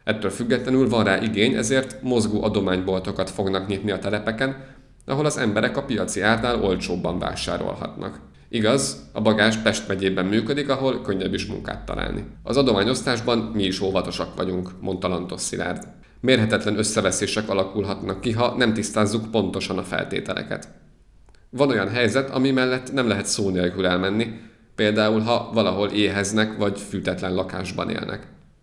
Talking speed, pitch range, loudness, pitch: 145 wpm, 95-120 Hz, -23 LUFS, 105 Hz